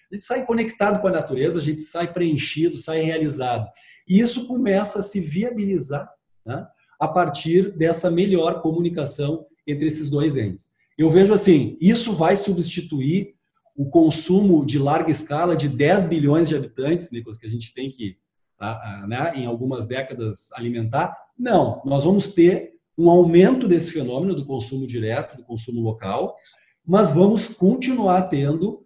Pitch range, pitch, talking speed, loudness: 140-185 Hz, 160 Hz, 155 wpm, -20 LUFS